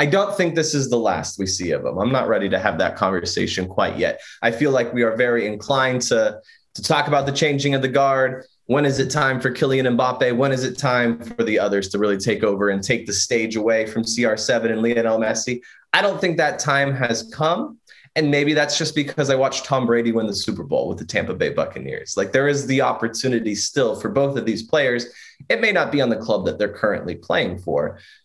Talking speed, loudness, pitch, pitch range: 240 wpm, -20 LUFS, 130 Hz, 115-140 Hz